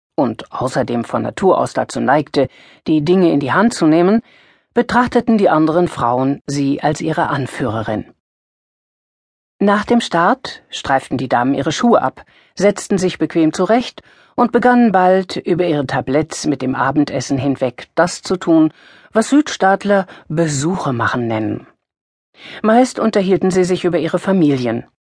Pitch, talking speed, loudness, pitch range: 170 Hz, 145 wpm, -16 LUFS, 140-200 Hz